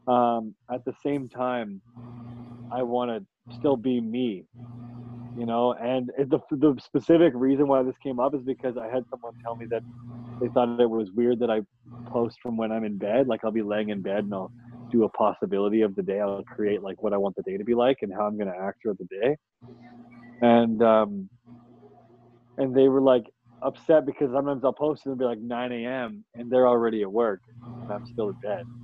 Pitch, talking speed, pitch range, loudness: 120 Hz, 220 wpm, 115-125 Hz, -26 LUFS